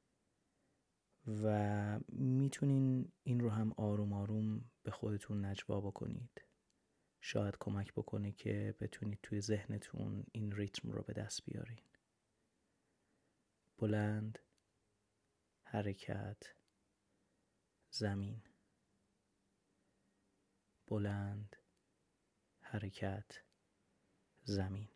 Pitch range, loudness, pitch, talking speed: 100-110 Hz, -42 LUFS, 105 Hz, 70 wpm